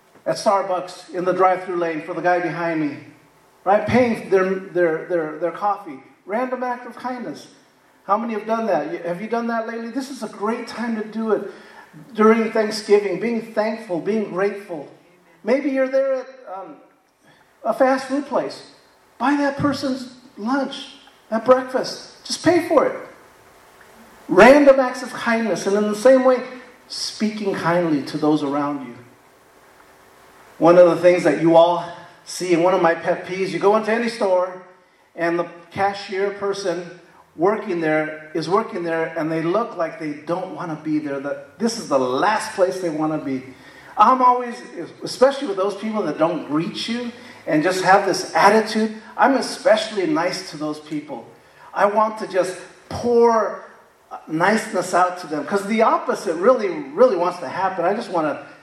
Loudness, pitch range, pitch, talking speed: -20 LUFS, 170-235 Hz, 200 Hz, 175 wpm